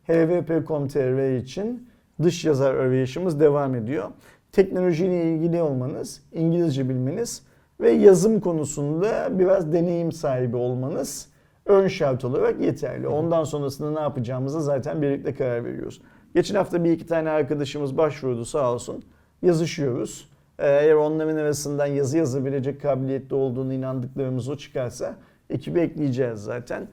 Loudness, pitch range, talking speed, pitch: -23 LUFS, 135-170 Hz, 120 wpm, 150 Hz